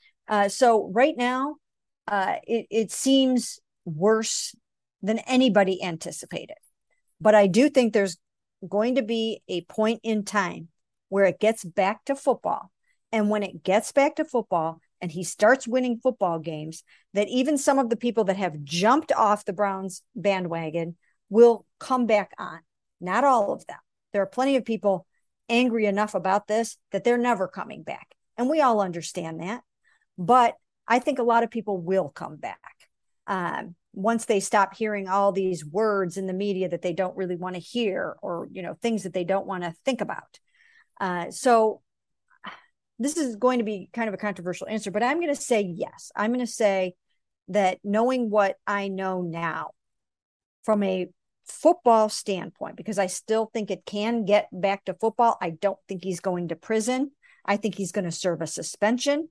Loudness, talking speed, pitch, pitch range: -25 LUFS, 180 wpm, 210 Hz, 190-235 Hz